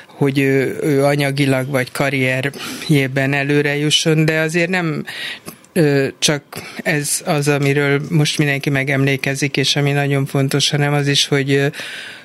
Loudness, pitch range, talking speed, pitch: -16 LUFS, 140-150 Hz, 130 wpm, 145 Hz